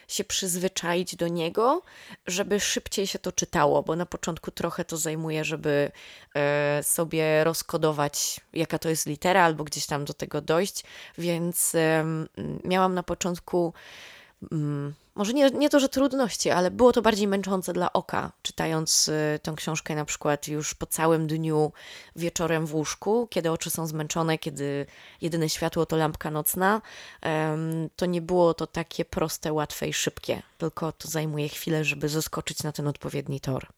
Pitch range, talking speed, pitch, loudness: 155-180 Hz, 155 wpm, 160 Hz, -26 LUFS